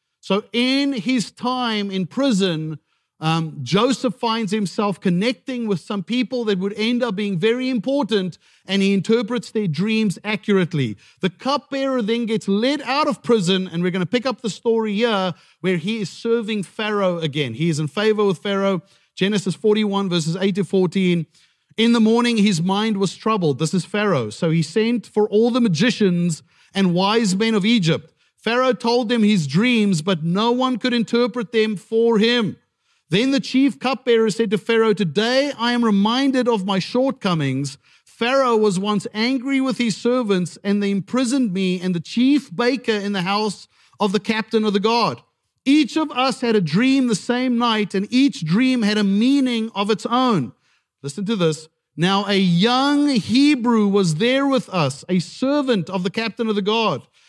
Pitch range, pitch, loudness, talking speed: 190-240 Hz, 215 Hz, -20 LUFS, 180 wpm